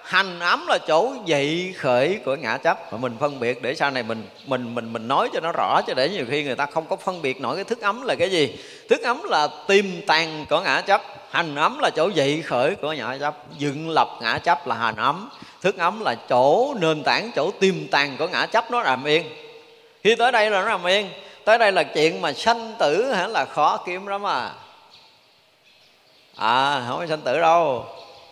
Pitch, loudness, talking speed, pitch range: 165 Hz, -22 LUFS, 225 wpm, 145-200 Hz